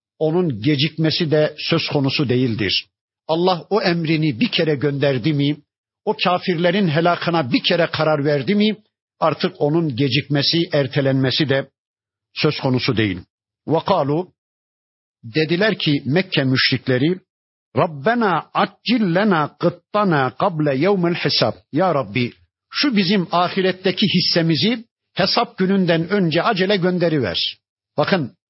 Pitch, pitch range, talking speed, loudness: 160 Hz, 135-185 Hz, 110 wpm, -19 LUFS